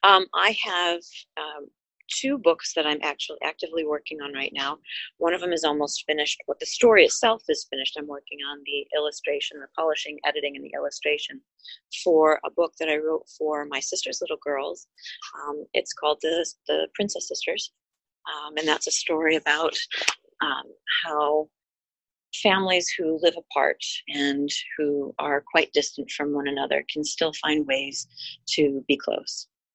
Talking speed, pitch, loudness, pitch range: 165 wpm, 155 Hz, -25 LUFS, 145-190 Hz